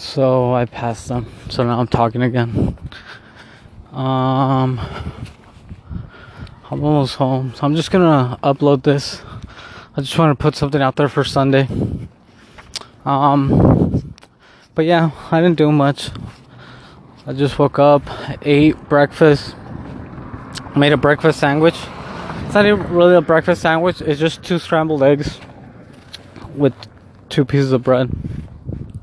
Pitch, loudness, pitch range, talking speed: 140 Hz, -16 LUFS, 125-150 Hz, 130 wpm